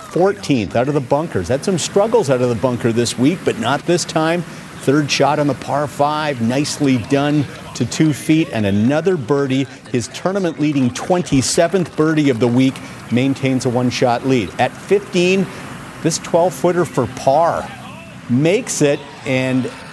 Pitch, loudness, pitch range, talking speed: 140 Hz, -17 LUFS, 130-165 Hz, 165 wpm